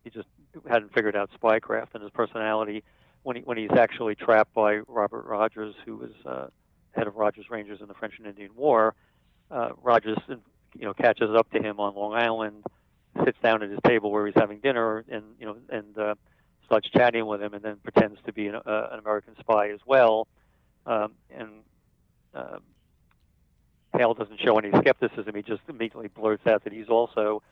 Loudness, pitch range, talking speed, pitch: -25 LUFS, 105-115 Hz, 190 wpm, 110 Hz